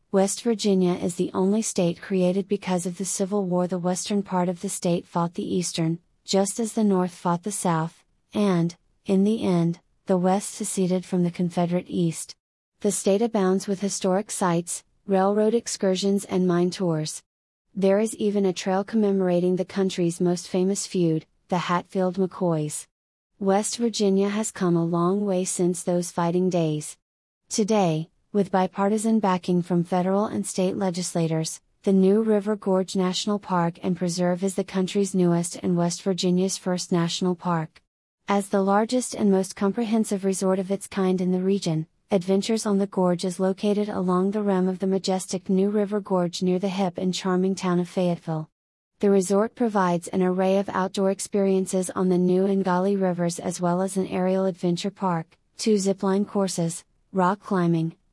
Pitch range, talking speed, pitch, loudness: 180-200 Hz, 170 wpm, 190 Hz, -24 LUFS